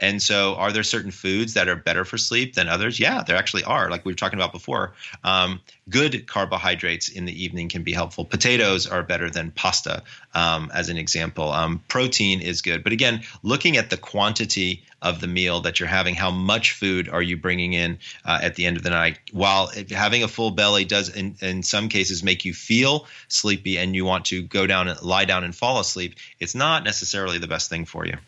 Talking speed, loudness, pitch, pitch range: 225 wpm, -21 LUFS, 95 Hz, 90-105 Hz